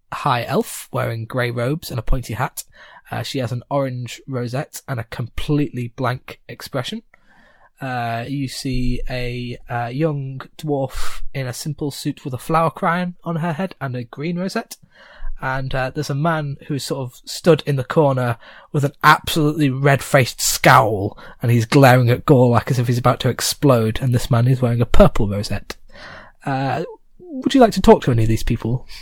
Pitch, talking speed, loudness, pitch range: 135 Hz, 185 wpm, -19 LUFS, 125-150 Hz